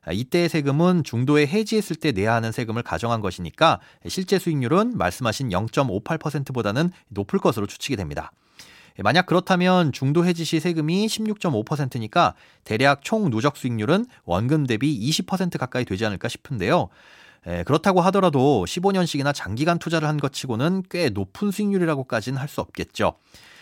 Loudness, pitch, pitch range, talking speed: -22 LUFS, 150 Hz, 115-180 Hz, 340 characters per minute